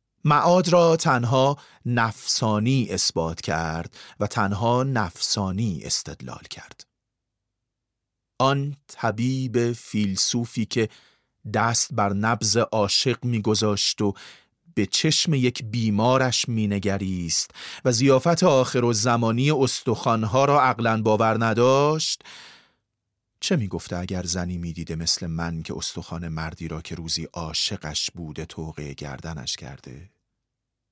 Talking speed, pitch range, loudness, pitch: 105 wpm, 95-125 Hz, -23 LUFS, 110 Hz